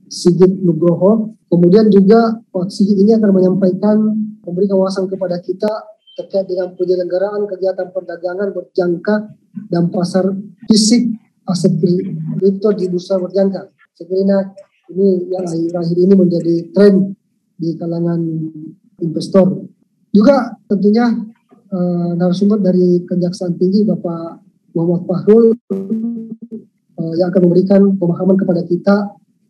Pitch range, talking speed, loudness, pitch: 180-205 Hz, 110 wpm, -14 LUFS, 190 Hz